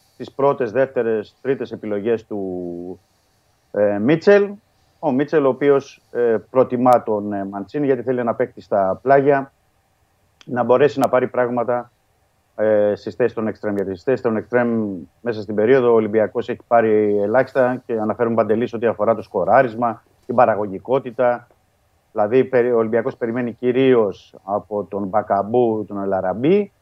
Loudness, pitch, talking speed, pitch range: -19 LUFS, 115 Hz, 145 wpm, 105-125 Hz